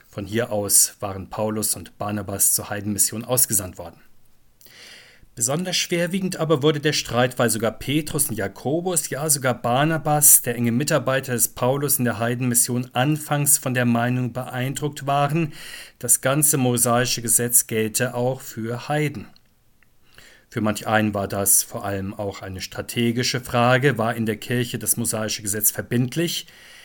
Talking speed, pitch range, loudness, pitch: 150 wpm, 110-140 Hz, -20 LUFS, 120 Hz